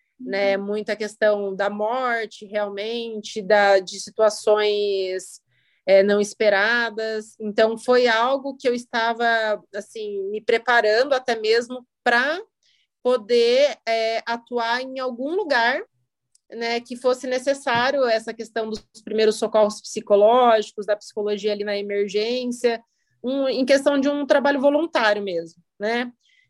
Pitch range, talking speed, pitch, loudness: 210-250 Hz, 120 wpm, 225 Hz, -21 LUFS